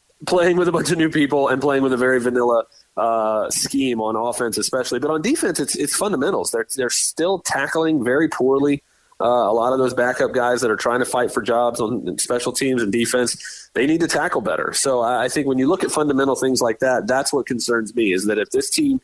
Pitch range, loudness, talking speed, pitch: 120-150 Hz, -19 LUFS, 235 wpm, 130 Hz